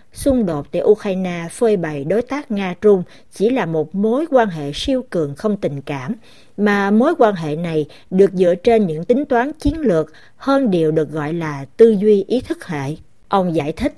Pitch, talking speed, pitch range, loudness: 195 Hz, 195 wpm, 160-235 Hz, -17 LUFS